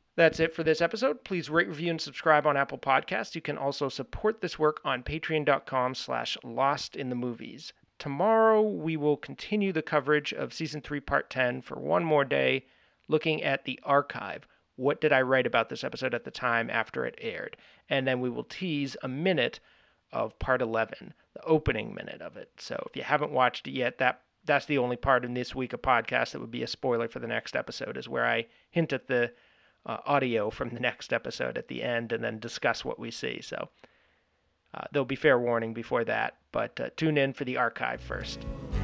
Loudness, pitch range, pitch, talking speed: -29 LUFS, 125-160 Hz, 140 Hz, 210 wpm